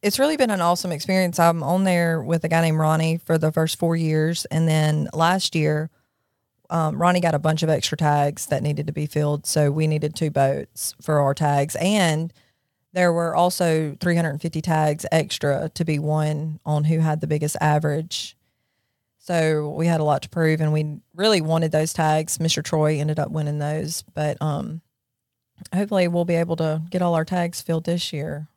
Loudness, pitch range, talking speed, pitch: -22 LUFS, 150-170 Hz, 195 wpm, 155 Hz